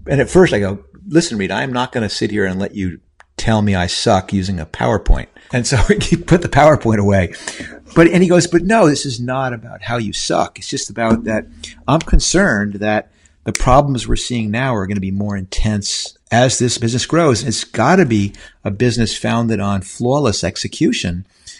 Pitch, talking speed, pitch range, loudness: 110 Hz, 210 wpm, 100-130 Hz, -16 LUFS